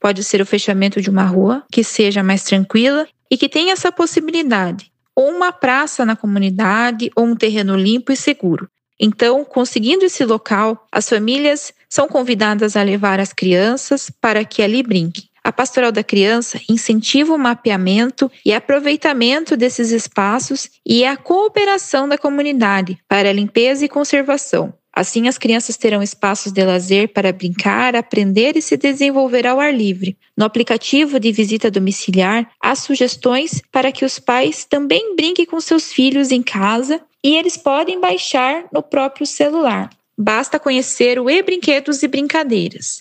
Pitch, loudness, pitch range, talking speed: 245 Hz, -15 LUFS, 210-285 Hz, 155 wpm